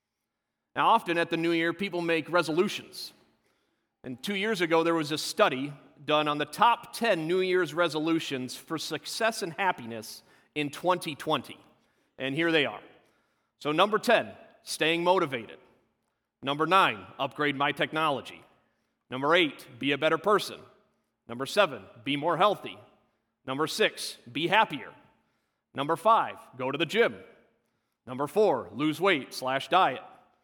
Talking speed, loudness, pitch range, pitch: 140 wpm, -27 LUFS, 145-185 Hz, 160 Hz